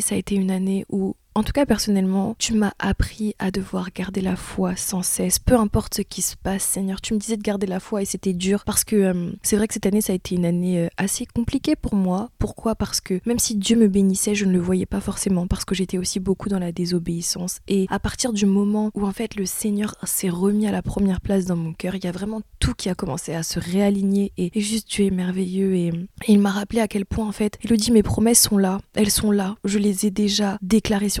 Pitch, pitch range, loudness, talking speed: 200 Hz, 185-210 Hz, -22 LUFS, 265 wpm